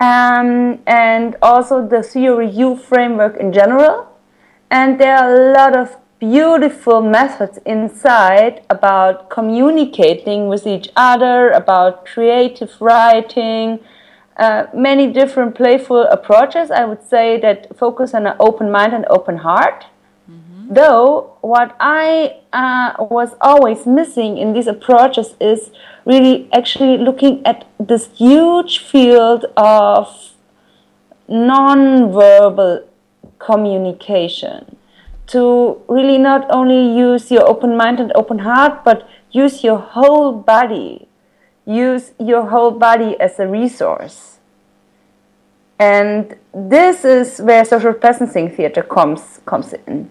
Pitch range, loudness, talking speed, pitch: 220-260 Hz, -11 LUFS, 115 wpm, 240 Hz